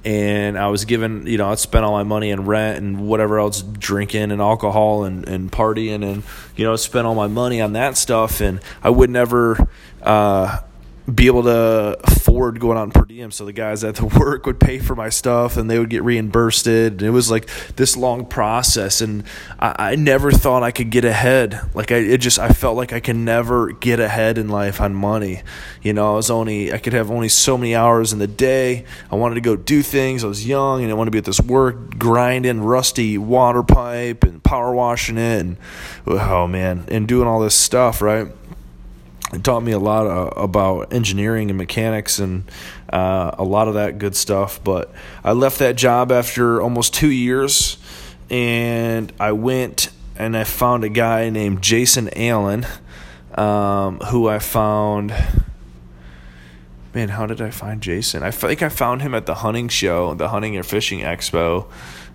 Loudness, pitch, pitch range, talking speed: -17 LUFS, 110 Hz, 100-120 Hz, 200 wpm